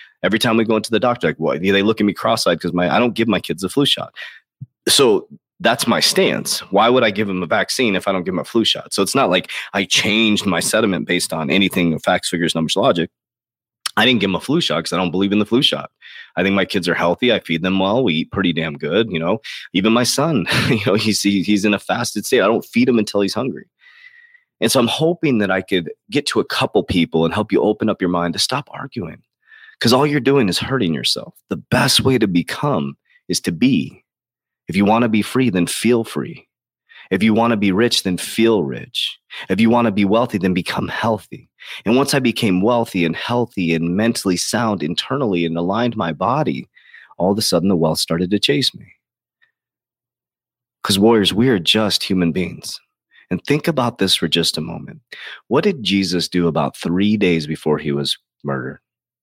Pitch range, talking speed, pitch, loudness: 85-115 Hz, 220 wpm, 100 Hz, -17 LUFS